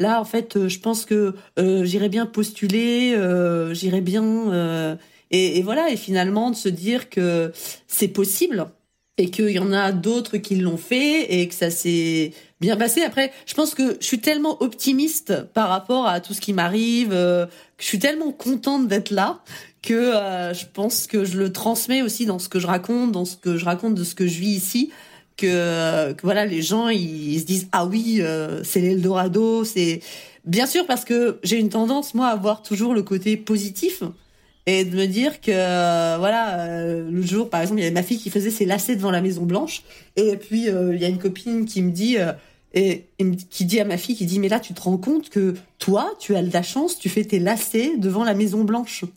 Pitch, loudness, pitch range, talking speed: 200 Hz, -21 LUFS, 180-230 Hz, 225 wpm